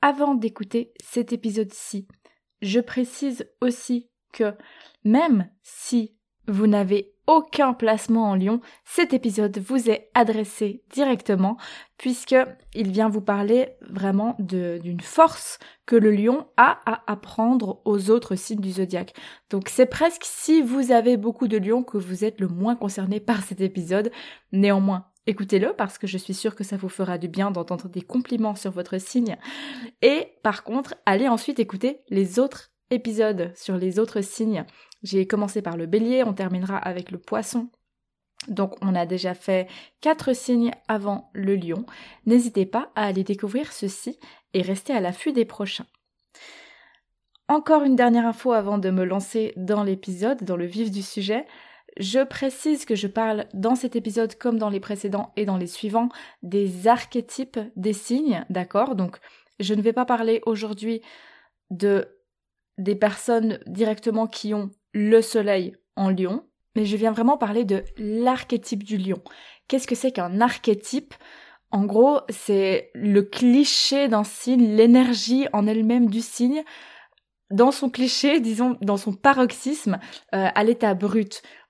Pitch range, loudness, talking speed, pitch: 200-250 Hz, -23 LUFS, 155 wpm, 220 Hz